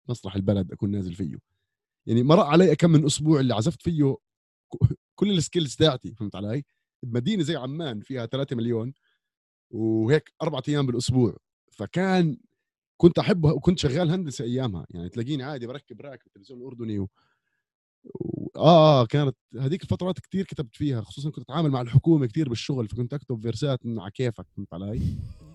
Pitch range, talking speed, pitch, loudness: 115-155 Hz, 155 wpm, 130 Hz, -24 LUFS